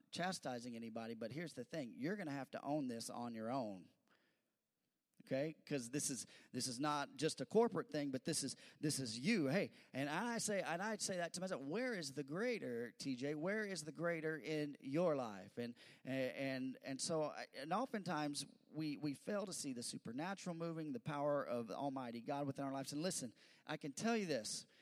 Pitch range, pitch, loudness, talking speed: 135-185 Hz, 150 Hz, -44 LUFS, 205 wpm